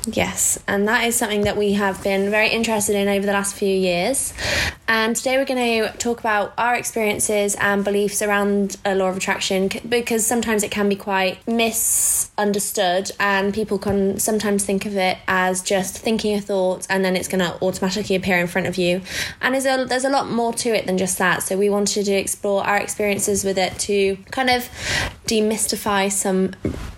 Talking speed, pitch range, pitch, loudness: 195 wpm, 190-220 Hz, 200 Hz, -20 LUFS